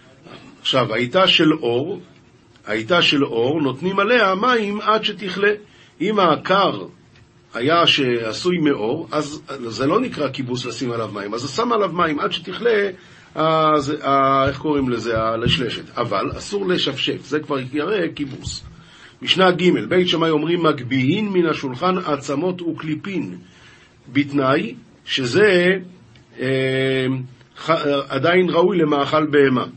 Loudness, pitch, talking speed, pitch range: -19 LUFS, 150 Hz, 125 wpm, 130-175 Hz